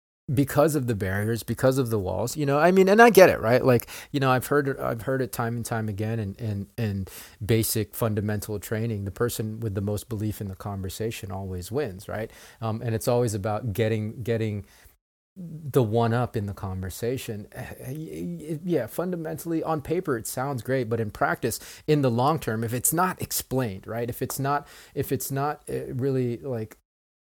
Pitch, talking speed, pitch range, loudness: 115 Hz, 190 wpm, 110-135 Hz, -26 LUFS